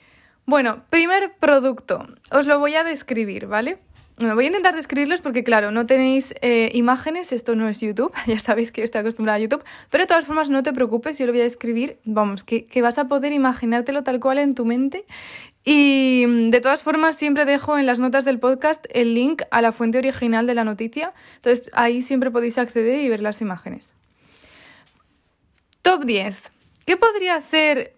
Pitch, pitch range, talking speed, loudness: 255 Hz, 235-290 Hz, 195 wpm, -19 LUFS